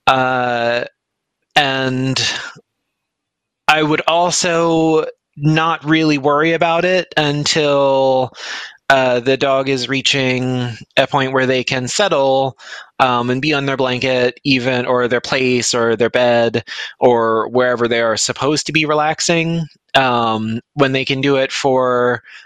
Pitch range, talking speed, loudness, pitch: 125-150 Hz, 135 wpm, -15 LUFS, 135 Hz